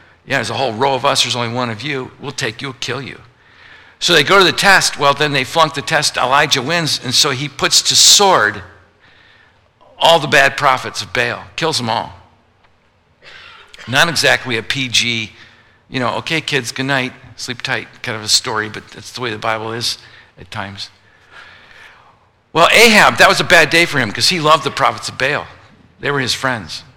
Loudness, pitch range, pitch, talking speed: -13 LUFS, 115-150 Hz, 130 Hz, 205 wpm